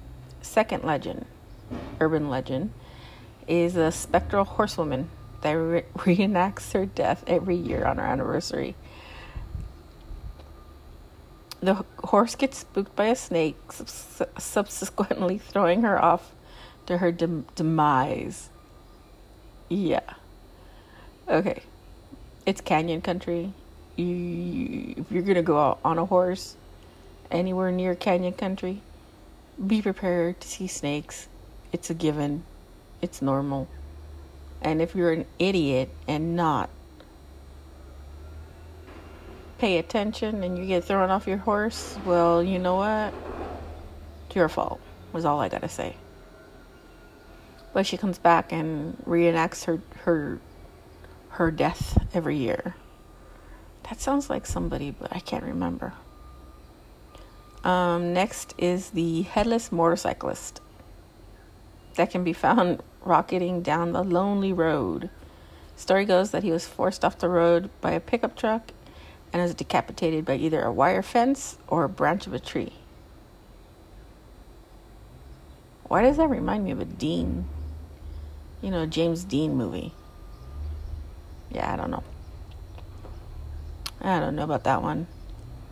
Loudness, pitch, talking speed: -26 LUFS, 160 Hz, 125 wpm